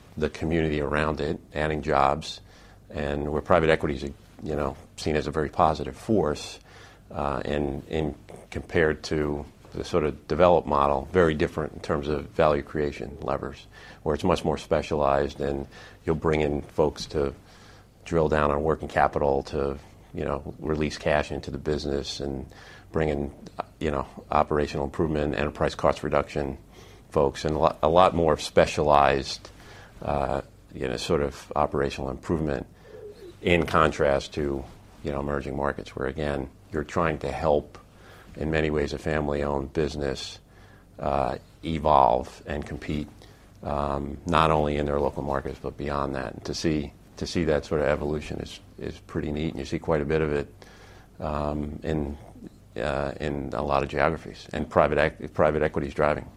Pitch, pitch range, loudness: 75 Hz, 70-80 Hz, -26 LUFS